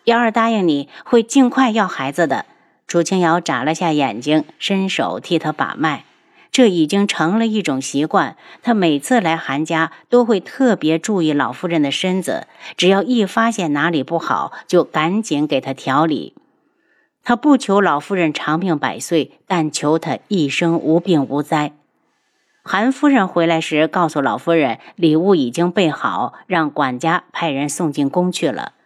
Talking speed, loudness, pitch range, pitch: 240 characters per minute, -17 LUFS, 155-215 Hz, 170 Hz